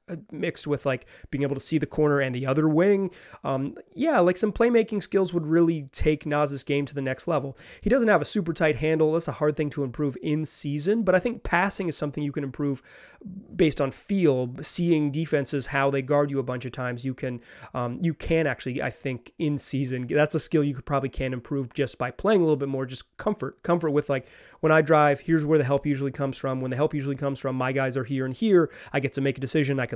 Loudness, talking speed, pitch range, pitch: -25 LUFS, 250 wpm, 135-160 Hz, 145 Hz